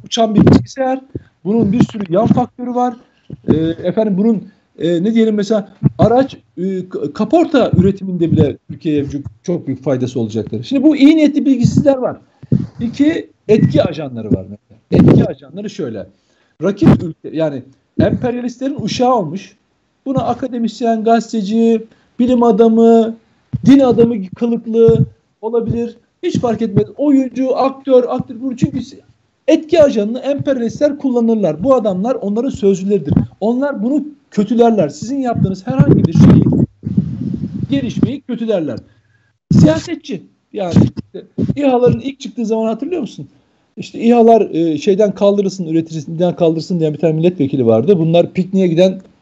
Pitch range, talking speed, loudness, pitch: 170-245 Hz, 125 wpm, -14 LUFS, 220 Hz